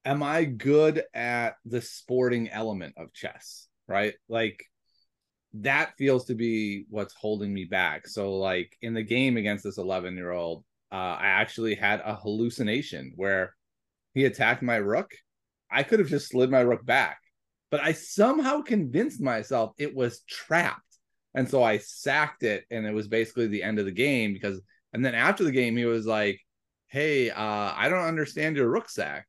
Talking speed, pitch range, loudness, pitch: 180 wpm, 105-135 Hz, -27 LUFS, 115 Hz